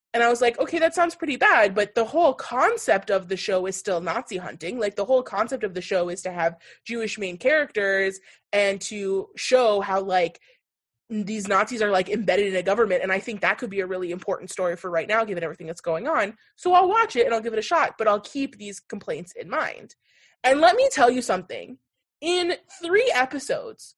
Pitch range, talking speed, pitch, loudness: 190-260 Hz, 225 wpm, 210 Hz, -23 LUFS